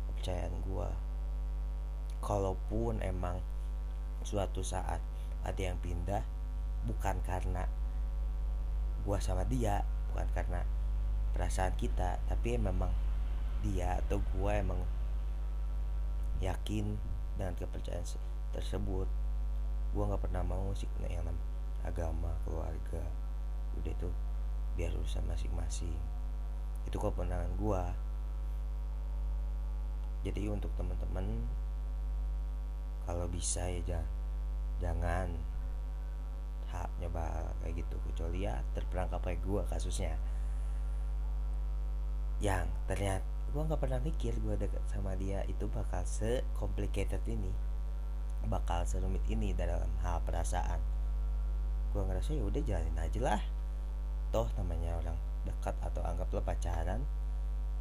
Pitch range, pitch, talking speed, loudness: 75-95 Hz, 85 Hz, 100 wpm, -38 LUFS